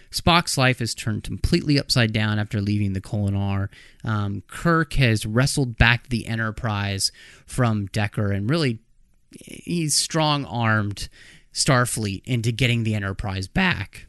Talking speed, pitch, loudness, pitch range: 130 wpm, 115 Hz, -22 LUFS, 100-130 Hz